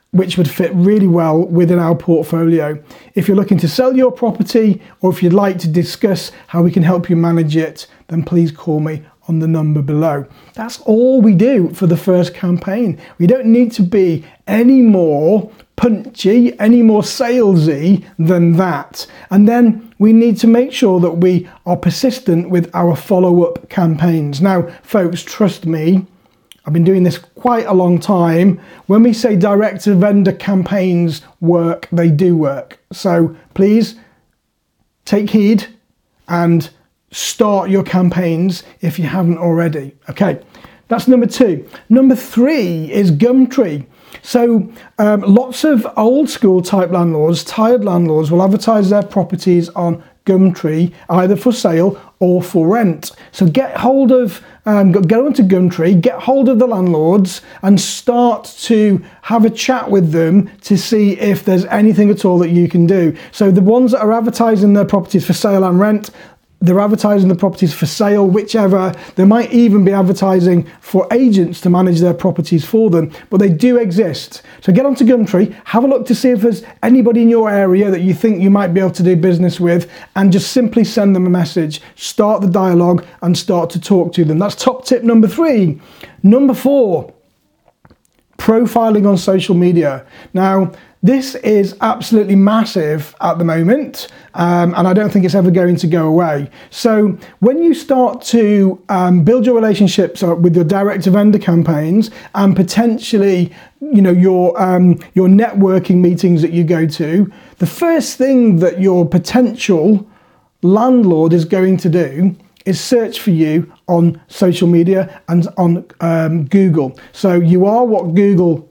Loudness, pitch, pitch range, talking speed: -12 LUFS, 190 Hz, 175-220 Hz, 165 wpm